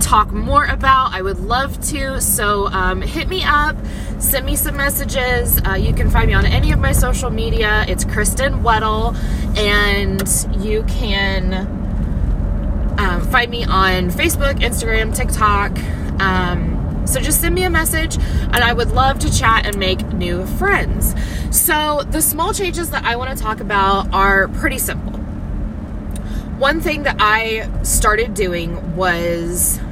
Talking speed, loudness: 155 wpm, -17 LUFS